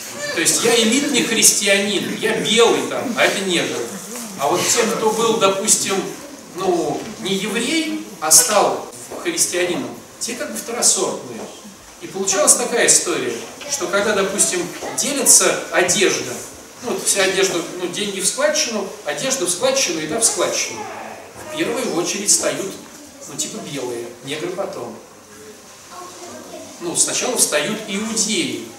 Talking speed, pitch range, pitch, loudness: 130 wpm, 190-235 Hz, 210 Hz, -17 LUFS